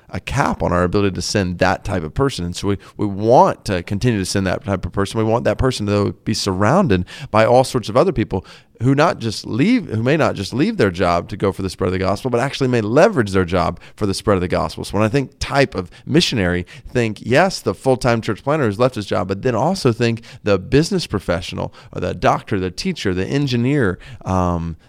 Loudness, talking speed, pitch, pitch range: -18 LUFS, 240 wpm, 105 Hz, 95-130 Hz